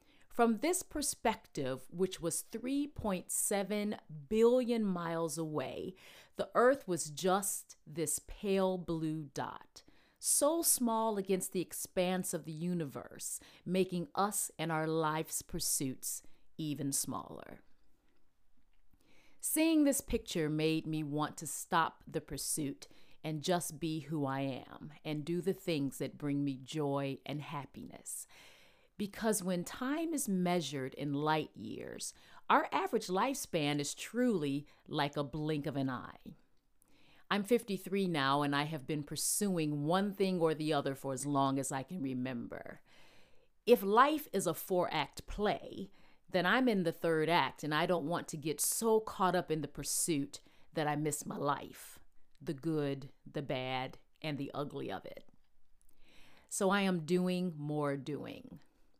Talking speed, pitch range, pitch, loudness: 145 wpm, 145-195 Hz, 165 Hz, -35 LUFS